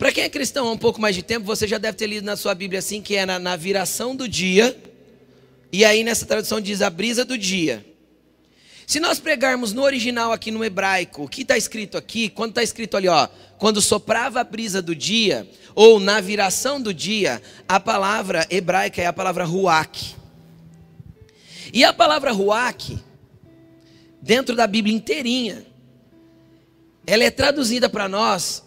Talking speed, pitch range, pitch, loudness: 175 wpm, 180-230 Hz, 210 Hz, -19 LUFS